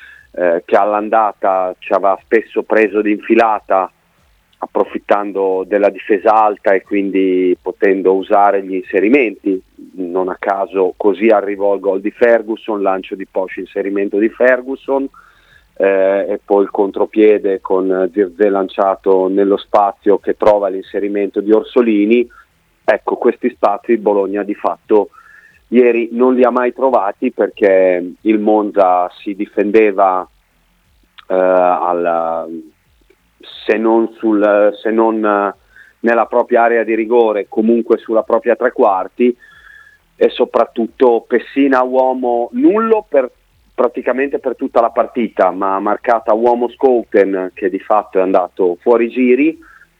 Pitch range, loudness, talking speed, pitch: 95-120 Hz, -14 LUFS, 125 wpm, 105 Hz